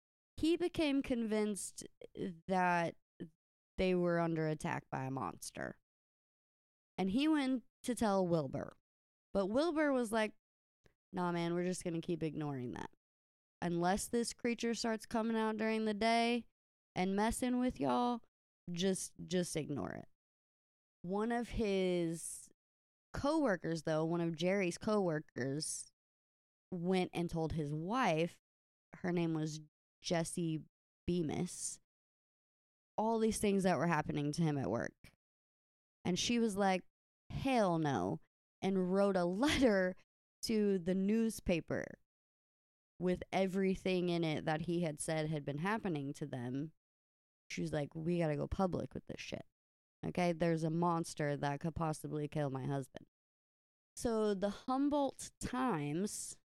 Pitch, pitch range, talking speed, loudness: 175 Hz, 155-215 Hz, 135 wpm, -37 LUFS